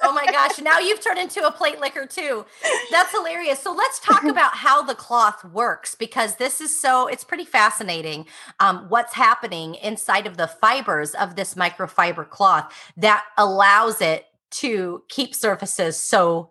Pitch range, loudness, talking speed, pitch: 195-300 Hz, -20 LUFS, 165 wpm, 235 Hz